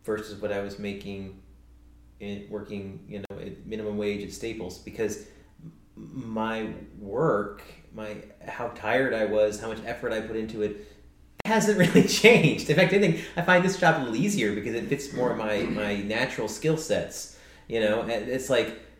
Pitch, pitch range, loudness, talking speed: 105 Hz, 100-130 Hz, -26 LUFS, 185 wpm